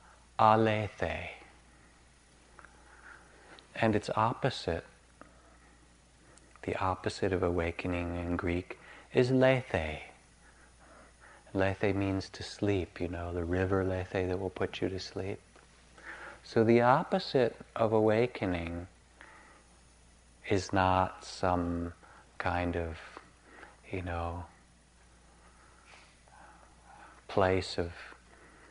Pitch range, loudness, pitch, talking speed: 70-95 Hz, -32 LUFS, 90 Hz, 85 wpm